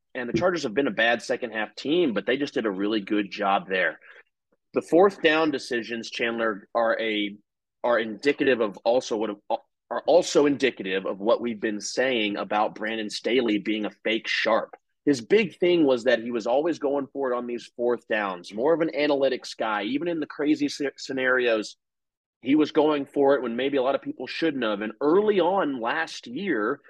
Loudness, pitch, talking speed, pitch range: -25 LUFS, 125 Hz, 200 wpm, 110-145 Hz